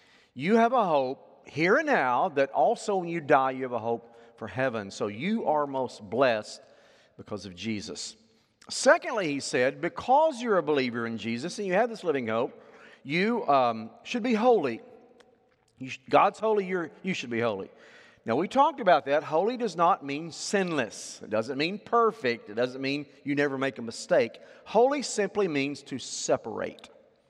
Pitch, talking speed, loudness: 160 Hz, 180 wpm, -27 LUFS